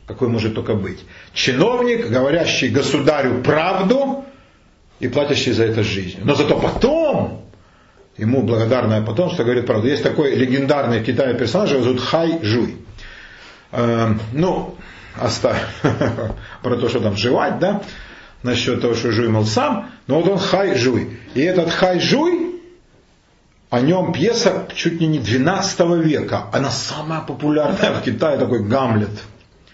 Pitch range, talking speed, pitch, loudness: 115-170 Hz, 140 wpm, 130 Hz, -18 LUFS